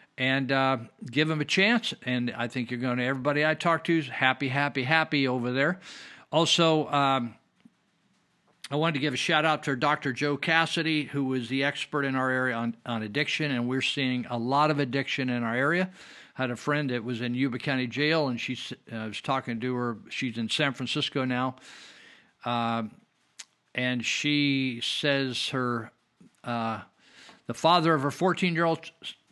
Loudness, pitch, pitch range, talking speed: -27 LUFS, 135 Hz, 125-150 Hz, 185 wpm